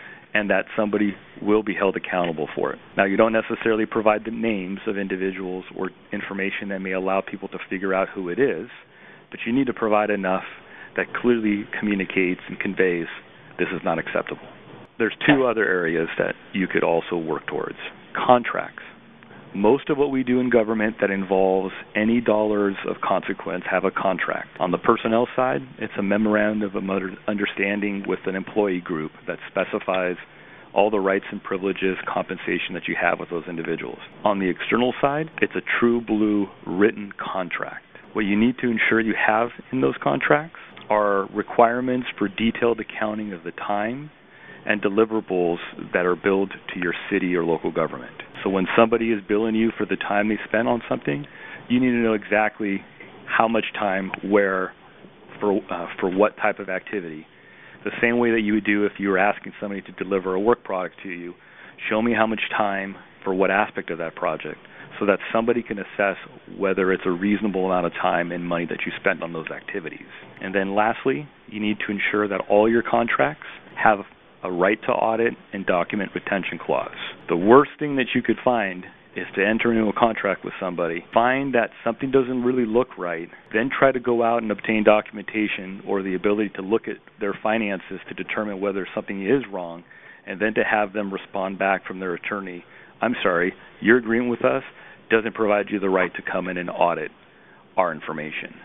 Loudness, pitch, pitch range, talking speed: -23 LUFS, 105 Hz, 95-115 Hz, 190 wpm